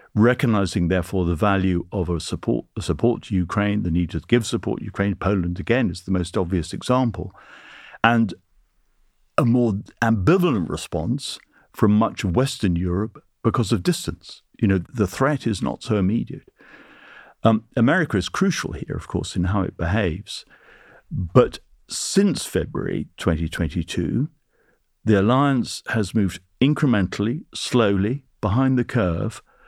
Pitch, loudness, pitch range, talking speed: 105 Hz, -22 LUFS, 90-120 Hz, 140 wpm